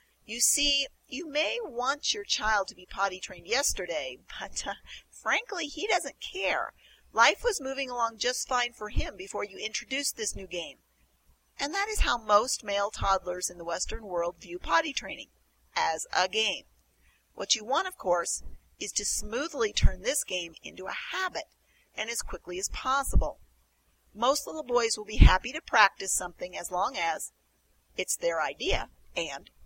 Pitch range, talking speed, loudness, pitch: 190-300 Hz, 170 wpm, -29 LUFS, 235 Hz